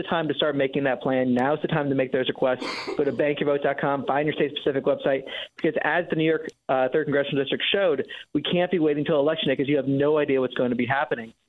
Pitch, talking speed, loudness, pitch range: 145 Hz, 255 wpm, -24 LUFS, 135-150 Hz